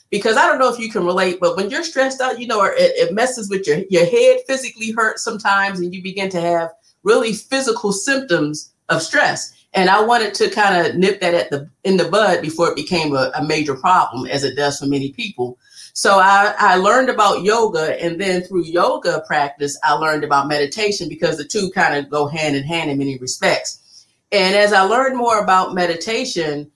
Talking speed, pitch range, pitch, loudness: 215 wpm, 155-220 Hz, 185 Hz, -17 LUFS